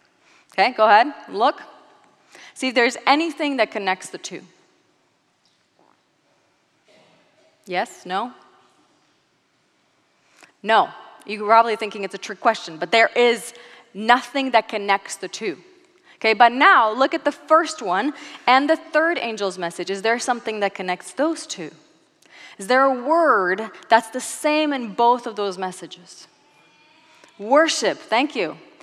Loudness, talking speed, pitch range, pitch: -20 LUFS, 135 wpm, 215-310 Hz, 245 Hz